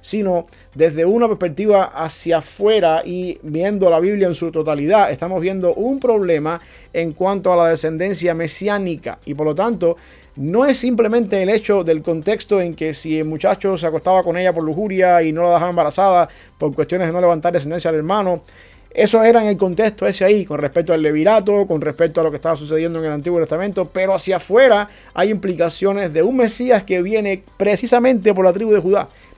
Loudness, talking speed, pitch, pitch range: -17 LUFS, 195 wpm, 180 Hz, 165-200 Hz